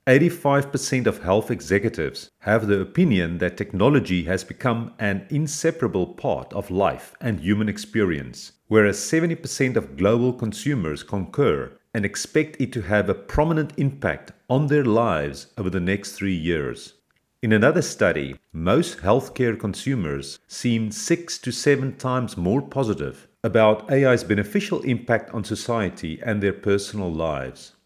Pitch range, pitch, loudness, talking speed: 100-135 Hz, 115 Hz, -23 LUFS, 140 wpm